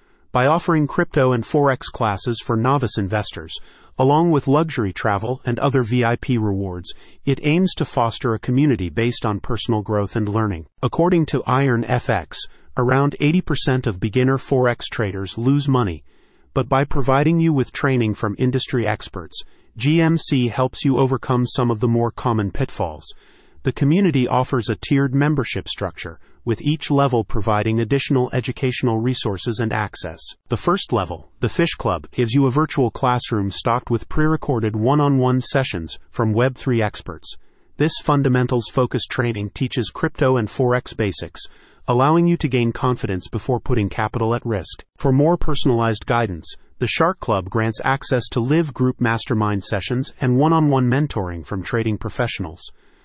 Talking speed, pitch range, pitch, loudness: 155 wpm, 110-140 Hz, 125 Hz, -20 LUFS